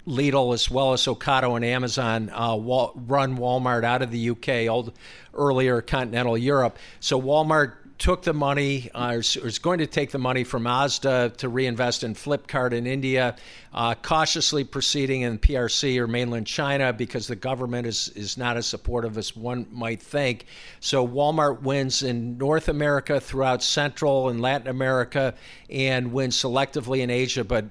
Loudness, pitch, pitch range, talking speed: -24 LUFS, 130 Hz, 120-135 Hz, 165 wpm